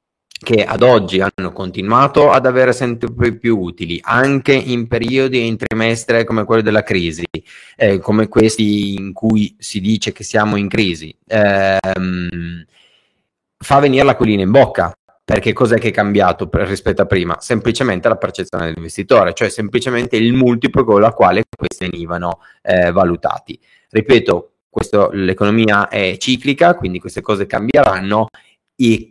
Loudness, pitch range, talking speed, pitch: -14 LUFS, 95-120 Hz, 150 wpm, 110 Hz